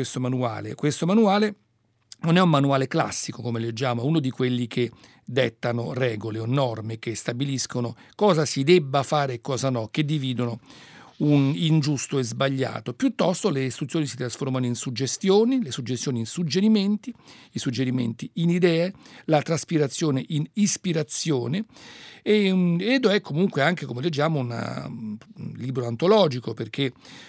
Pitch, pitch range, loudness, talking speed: 135 Hz, 125-170 Hz, -24 LUFS, 145 wpm